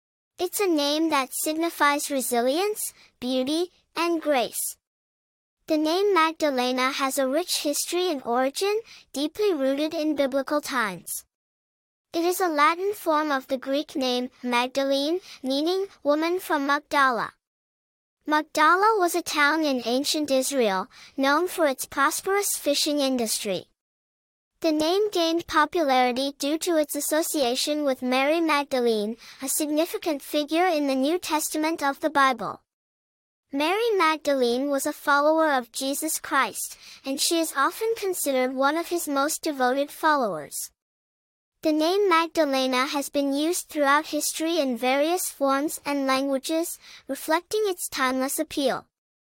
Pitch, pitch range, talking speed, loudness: 295 Hz, 270-325 Hz, 130 wpm, -24 LUFS